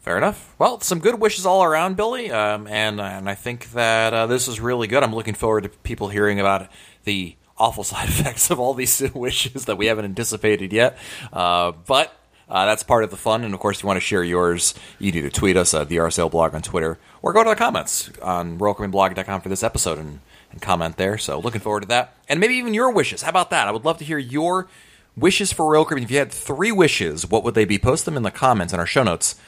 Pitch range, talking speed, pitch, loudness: 95-135 Hz, 250 wpm, 110 Hz, -20 LUFS